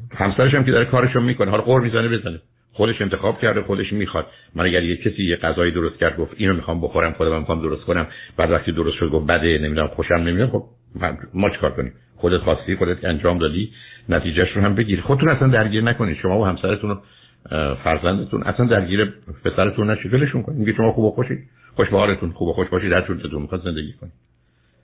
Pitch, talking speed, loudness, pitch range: 95 Hz, 205 wpm, -20 LUFS, 85-110 Hz